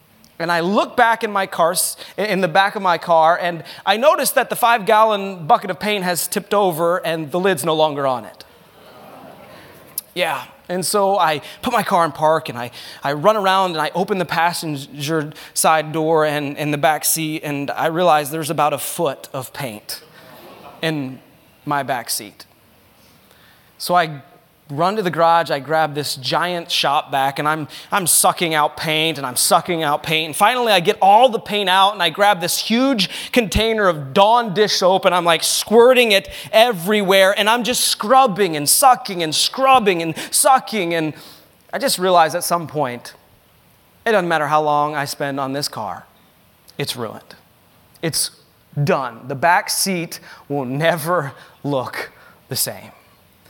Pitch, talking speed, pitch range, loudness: 170 Hz, 175 wpm, 155-200 Hz, -17 LUFS